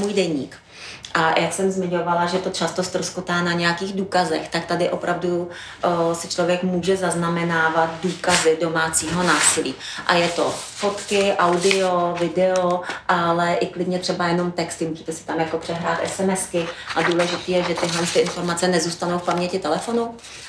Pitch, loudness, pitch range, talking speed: 175 Hz, -21 LUFS, 170-180 Hz, 150 wpm